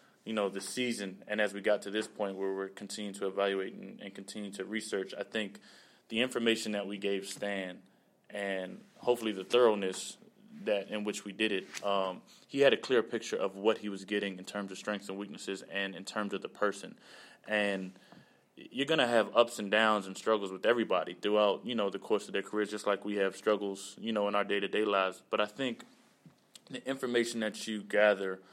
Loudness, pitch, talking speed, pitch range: -33 LUFS, 100 Hz, 215 wpm, 95-110 Hz